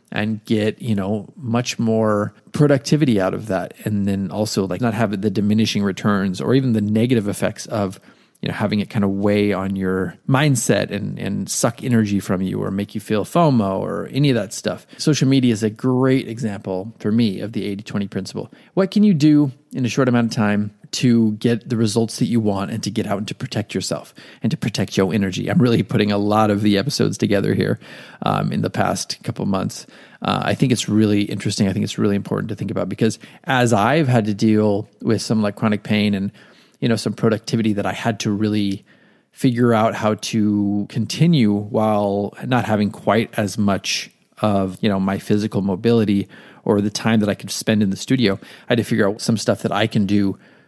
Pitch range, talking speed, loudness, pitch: 100-115 Hz, 215 wpm, -19 LUFS, 110 Hz